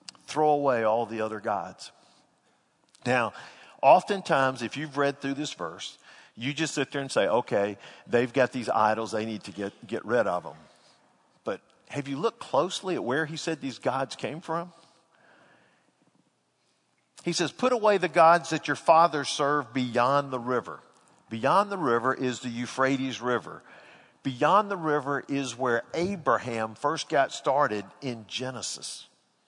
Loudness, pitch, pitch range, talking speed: -27 LUFS, 135 Hz, 120-160 Hz, 155 wpm